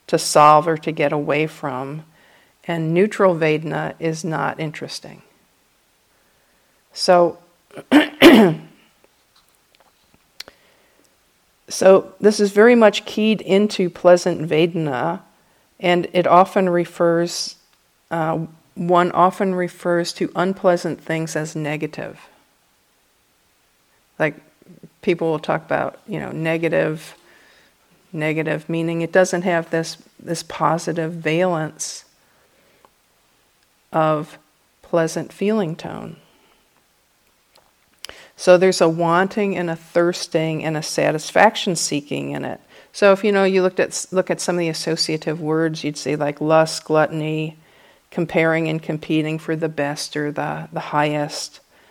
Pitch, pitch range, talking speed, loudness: 165 Hz, 155-180 Hz, 115 wpm, -19 LUFS